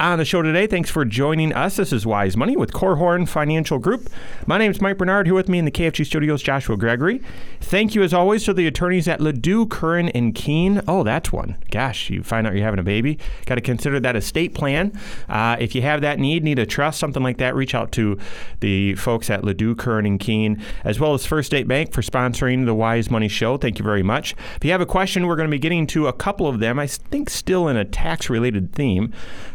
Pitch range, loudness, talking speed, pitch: 115-175 Hz, -20 LUFS, 245 wpm, 145 Hz